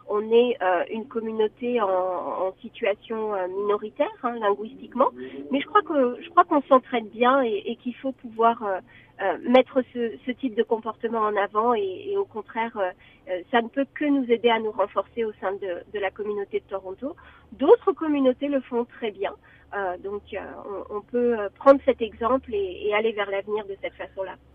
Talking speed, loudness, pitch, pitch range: 200 wpm, -25 LUFS, 225 Hz, 200-260 Hz